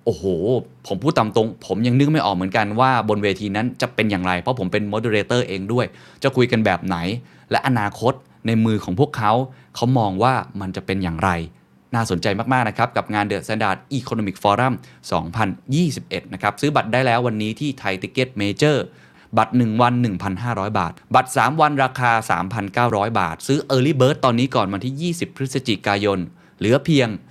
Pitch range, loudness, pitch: 100-130 Hz, -20 LUFS, 115 Hz